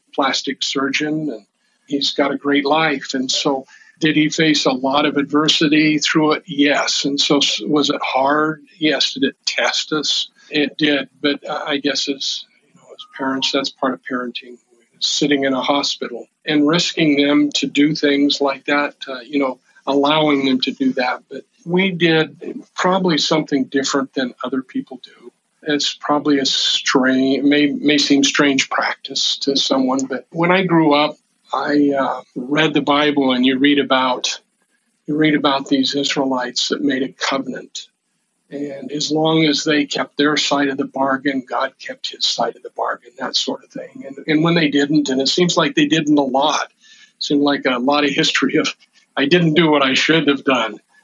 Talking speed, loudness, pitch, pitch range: 185 wpm, -17 LUFS, 145 Hz, 135-155 Hz